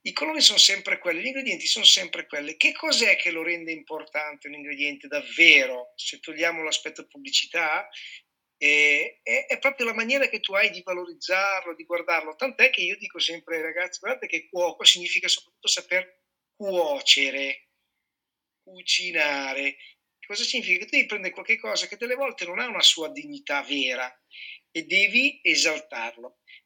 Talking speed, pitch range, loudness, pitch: 160 wpm, 155-220 Hz, -22 LUFS, 175 Hz